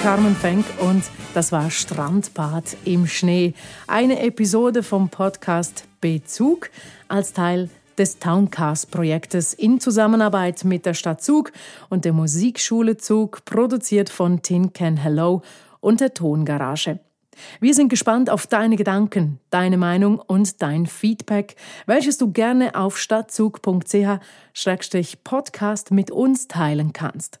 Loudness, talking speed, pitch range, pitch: -20 LUFS, 120 wpm, 170-220 Hz, 195 Hz